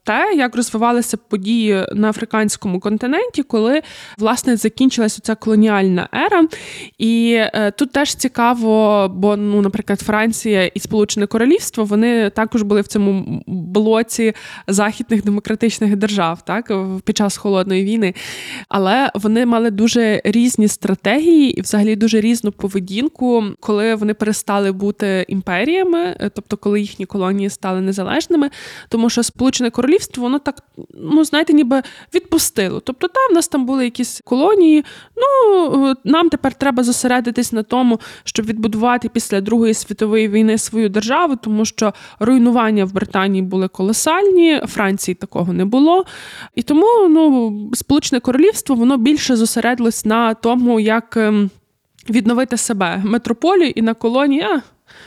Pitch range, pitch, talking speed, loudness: 210-260 Hz, 225 Hz, 135 wpm, -16 LUFS